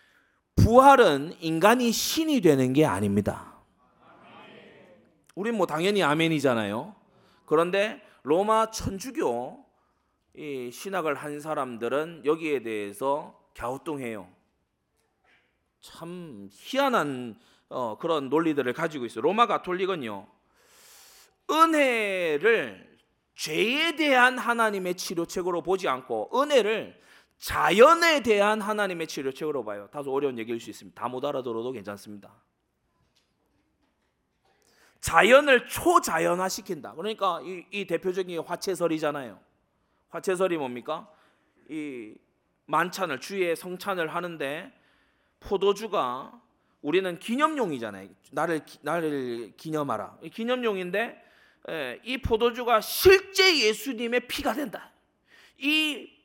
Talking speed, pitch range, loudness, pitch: 245 characters per minute, 145-235 Hz, -25 LUFS, 180 Hz